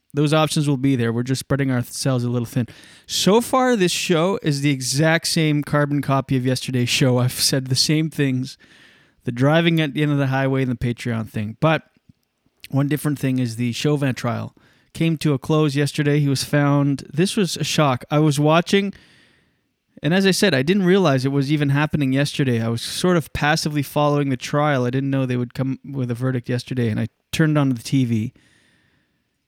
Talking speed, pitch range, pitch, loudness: 205 wpm, 130-155 Hz, 140 Hz, -20 LUFS